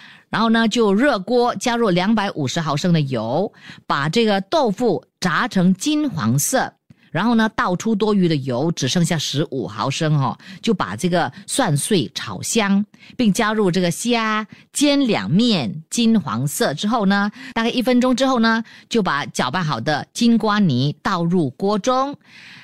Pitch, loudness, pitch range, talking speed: 200 Hz, -19 LUFS, 170-230 Hz, 235 characters per minute